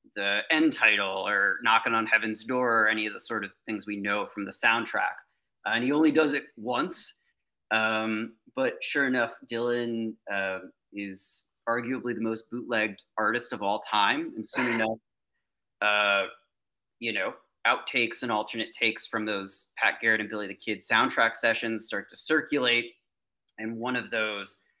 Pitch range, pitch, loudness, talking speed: 105-120 Hz, 110 Hz, -27 LUFS, 165 wpm